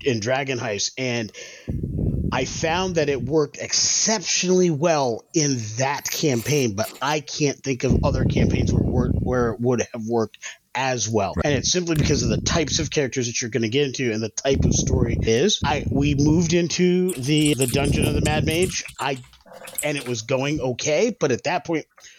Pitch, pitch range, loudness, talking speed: 140 Hz, 125-155 Hz, -22 LUFS, 200 wpm